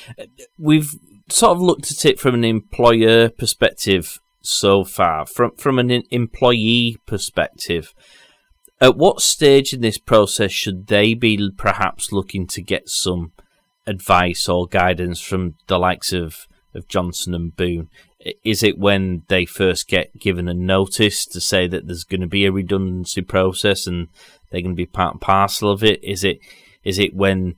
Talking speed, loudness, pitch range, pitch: 165 wpm, -17 LUFS, 90-115 Hz, 100 Hz